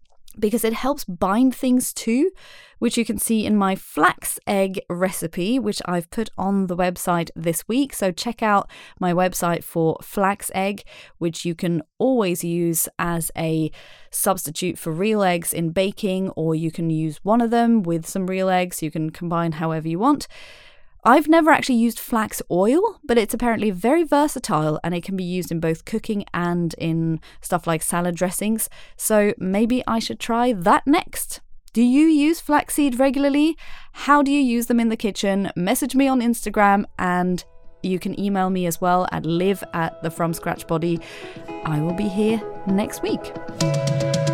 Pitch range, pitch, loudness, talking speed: 170-235 Hz, 195 Hz, -21 LUFS, 175 wpm